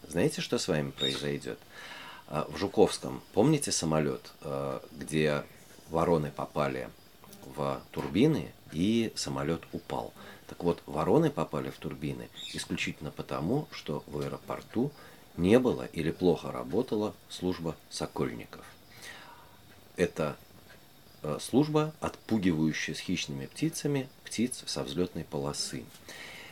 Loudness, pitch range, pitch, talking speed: -32 LUFS, 70-100 Hz, 80 Hz, 100 wpm